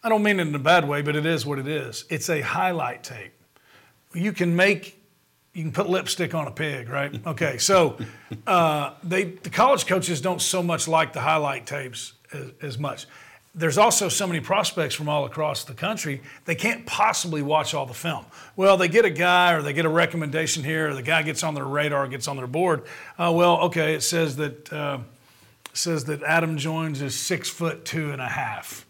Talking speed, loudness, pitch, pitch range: 215 wpm, -23 LUFS, 160 Hz, 145-175 Hz